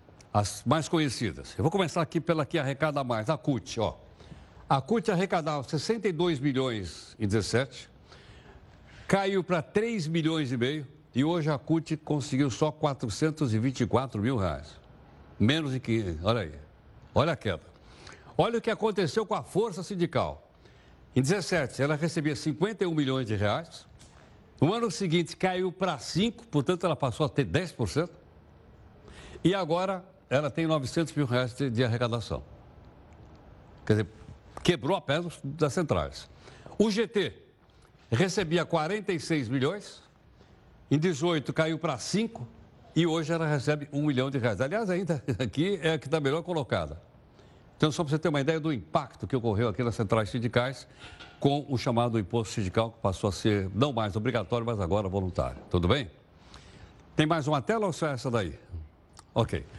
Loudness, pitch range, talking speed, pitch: -29 LUFS, 115-170 Hz, 160 wpm, 145 Hz